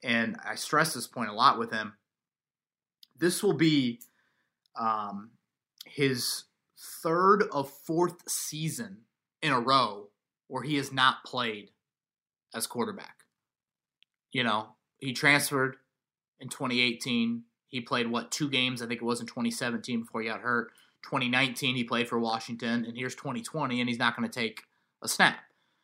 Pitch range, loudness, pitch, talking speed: 115-135 Hz, -29 LUFS, 125 Hz, 150 wpm